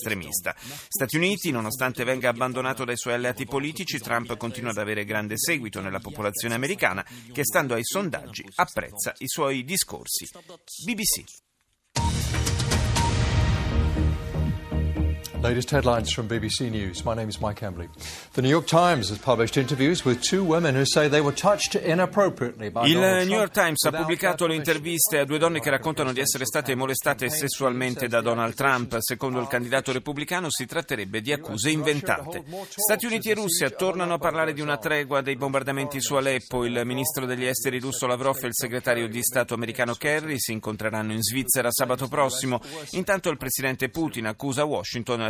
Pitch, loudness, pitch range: 130 Hz, -25 LUFS, 120-155 Hz